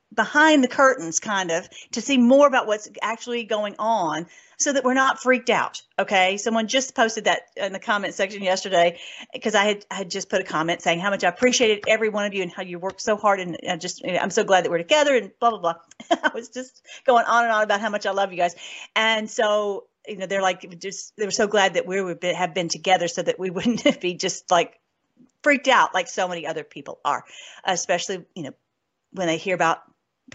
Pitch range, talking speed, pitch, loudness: 180-230 Hz, 240 wpm, 200 Hz, -22 LUFS